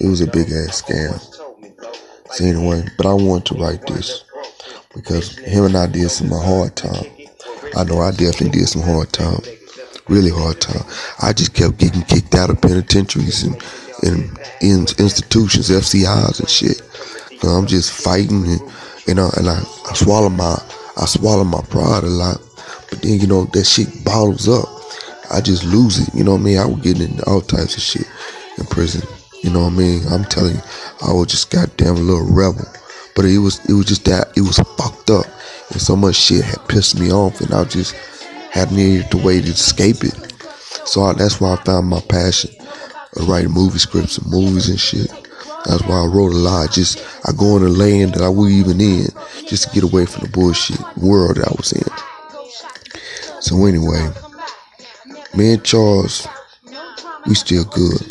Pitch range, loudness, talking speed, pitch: 85-100 Hz, -15 LUFS, 195 wpm, 95 Hz